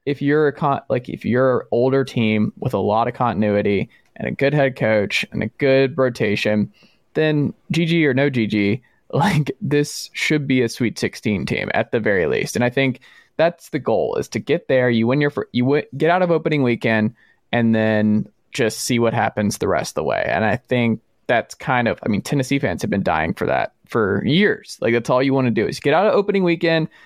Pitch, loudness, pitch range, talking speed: 130 Hz, -19 LUFS, 115-145 Hz, 230 wpm